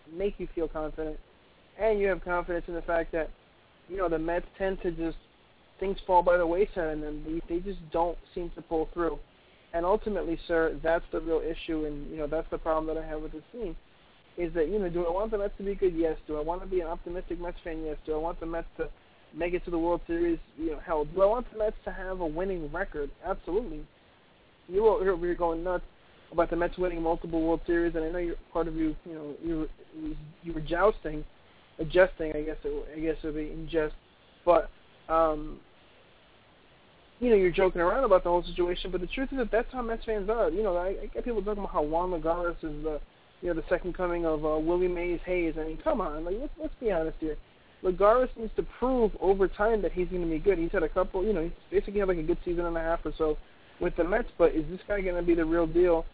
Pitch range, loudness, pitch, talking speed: 160-185 Hz, -30 LUFS, 170 Hz, 250 wpm